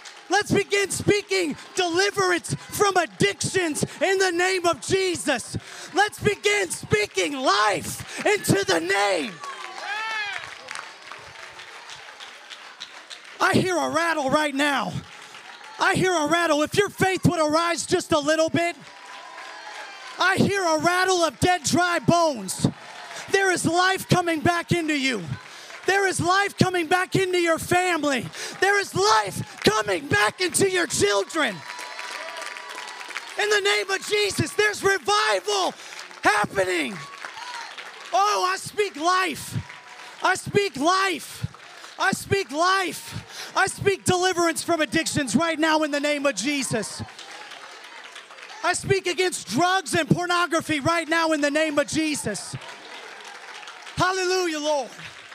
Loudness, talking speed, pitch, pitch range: -23 LUFS, 125 wpm, 355 Hz, 310-385 Hz